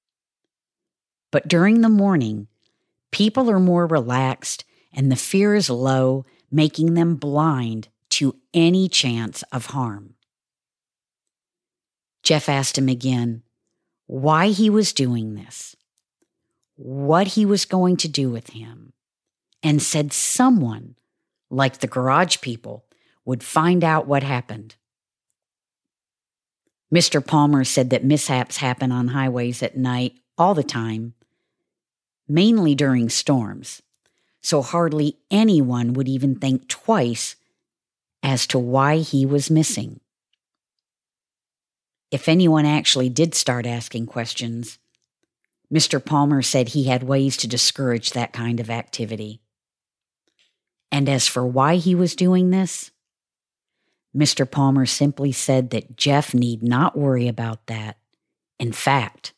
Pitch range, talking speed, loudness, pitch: 120-155 Hz, 120 wpm, -20 LUFS, 135 Hz